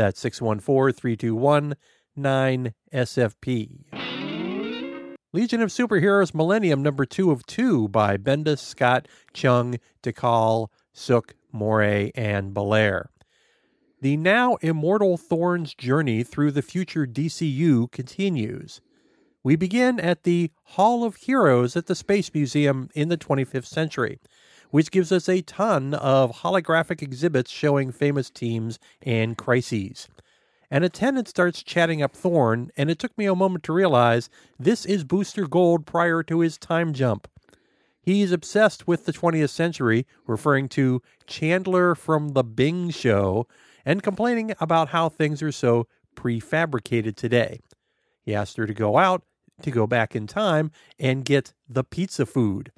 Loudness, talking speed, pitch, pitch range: -23 LUFS, 135 wpm, 145 Hz, 120-175 Hz